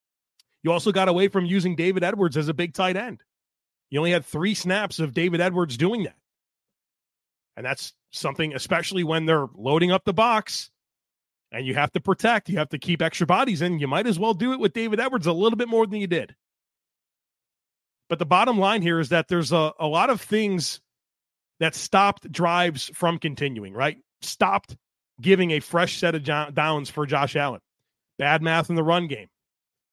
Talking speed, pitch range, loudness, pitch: 190 wpm, 155-195 Hz, -23 LUFS, 170 Hz